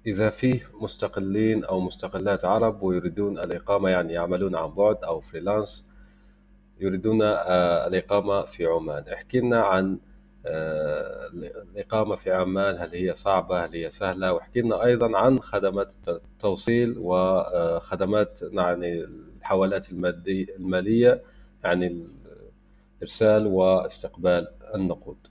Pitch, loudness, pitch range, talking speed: 95 Hz, -25 LUFS, 90-110 Hz, 100 wpm